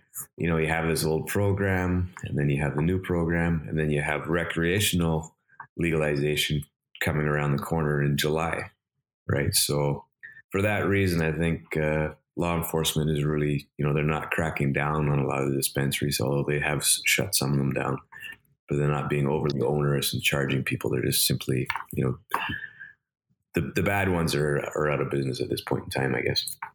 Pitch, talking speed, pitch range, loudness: 75 Hz, 190 wpm, 70-85 Hz, -26 LUFS